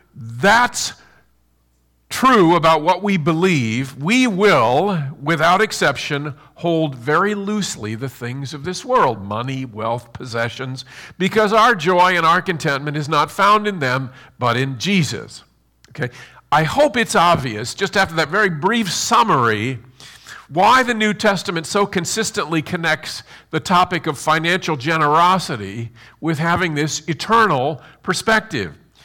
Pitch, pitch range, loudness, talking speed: 160 Hz, 130-190 Hz, -17 LUFS, 130 wpm